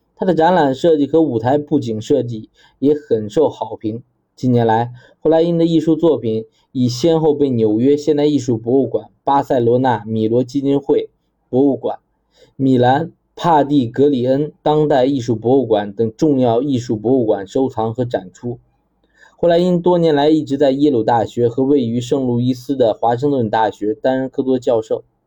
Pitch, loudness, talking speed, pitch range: 135 Hz, -16 LUFS, 270 characters per minute, 120-150 Hz